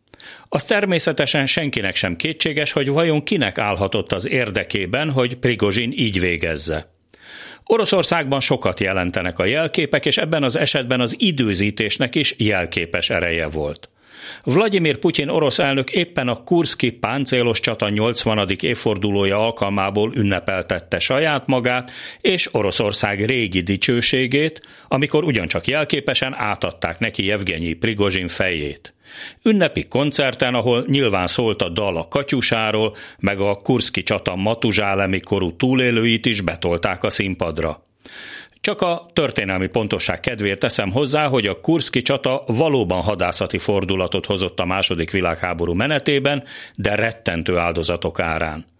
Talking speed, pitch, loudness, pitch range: 125 wpm, 115 Hz, -19 LUFS, 95-135 Hz